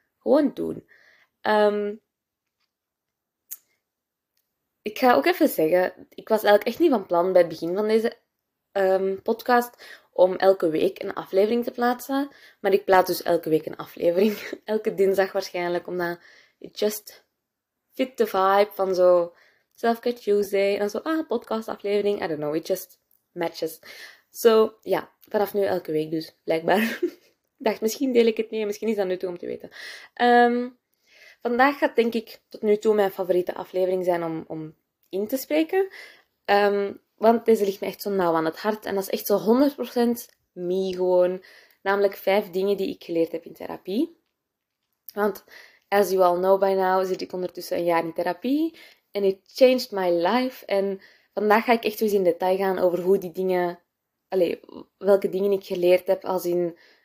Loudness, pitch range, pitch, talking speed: -23 LUFS, 180-225 Hz, 200 Hz, 180 wpm